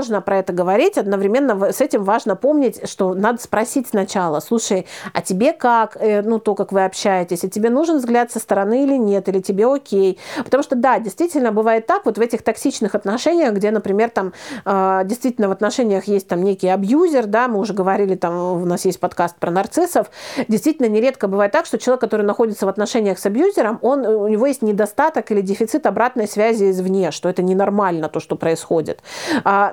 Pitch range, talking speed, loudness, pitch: 195-245 Hz, 190 wpm, -18 LUFS, 210 Hz